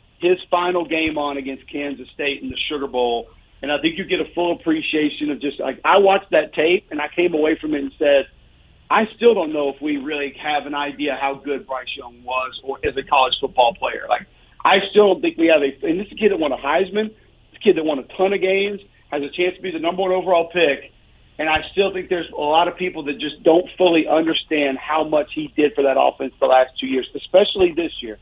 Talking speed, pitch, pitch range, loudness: 255 wpm, 155 Hz, 140-180 Hz, -19 LUFS